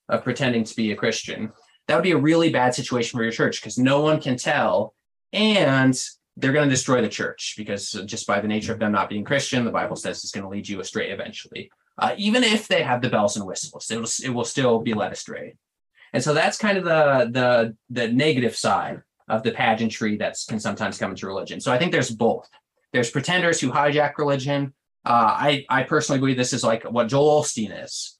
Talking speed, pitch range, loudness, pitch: 225 wpm, 115-150 Hz, -22 LUFS, 130 Hz